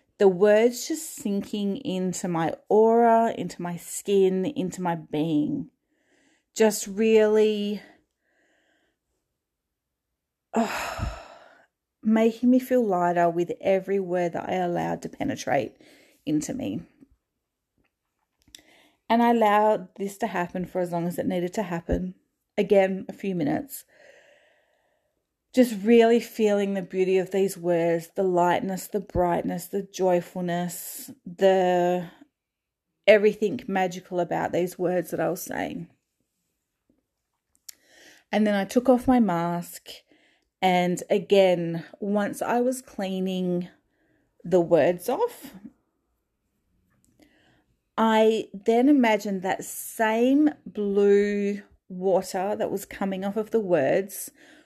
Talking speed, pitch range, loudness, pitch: 110 wpm, 180-235 Hz, -24 LUFS, 200 Hz